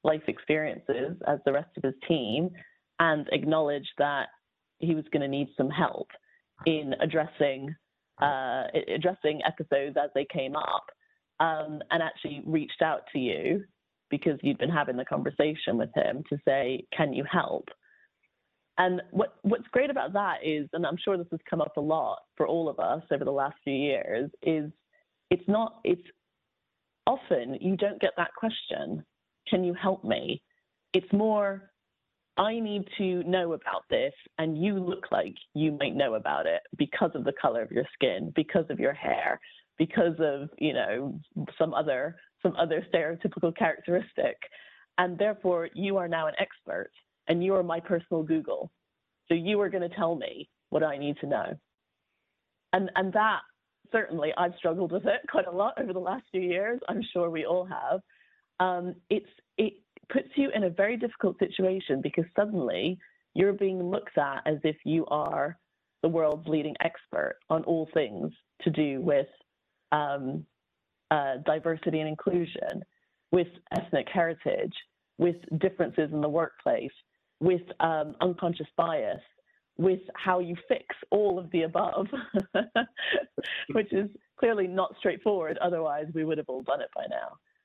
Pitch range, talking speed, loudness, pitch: 155-195 Hz, 165 wpm, -29 LUFS, 175 Hz